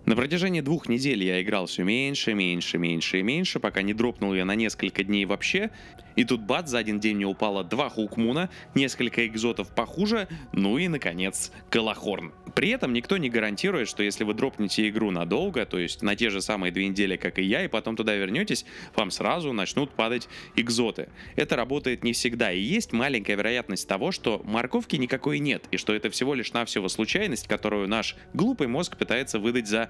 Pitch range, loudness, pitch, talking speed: 100-130 Hz, -26 LUFS, 110 Hz, 190 wpm